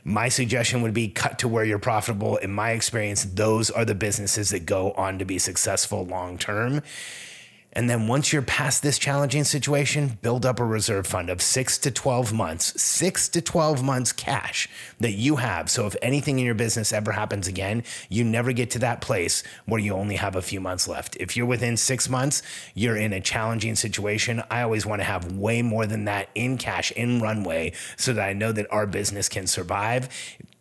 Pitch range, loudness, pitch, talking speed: 100-125 Hz, -24 LUFS, 110 Hz, 205 wpm